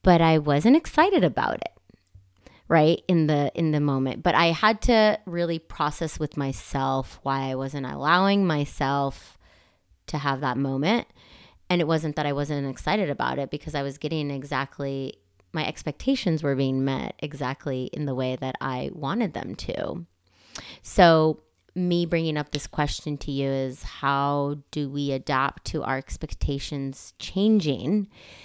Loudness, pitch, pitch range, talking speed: -25 LUFS, 145 Hz, 135-165 Hz, 155 wpm